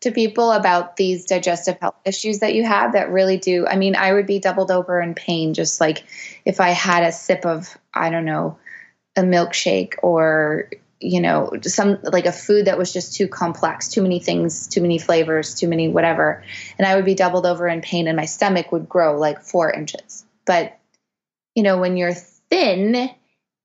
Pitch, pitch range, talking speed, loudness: 180 Hz, 170-200 Hz, 200 wpm, -19 LUFS